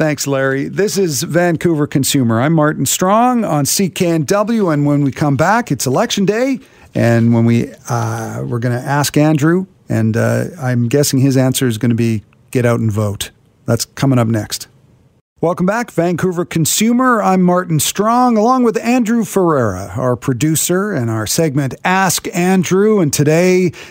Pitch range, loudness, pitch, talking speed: 125-185 Hz, -14 LUFS, 150 Hz, 165 wpm